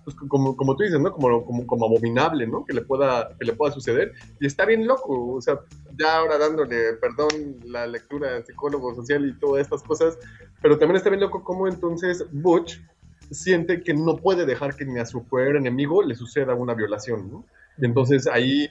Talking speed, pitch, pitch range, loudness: 200 wpm, 140 Hz, 120-155 Hz, -23 LUFS